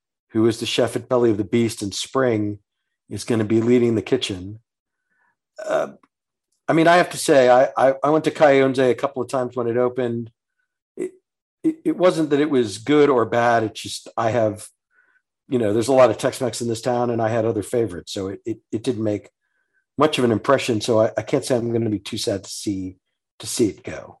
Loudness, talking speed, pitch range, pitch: -20 LUFS, 235 wpm, 110-140 Hz, 125 Hz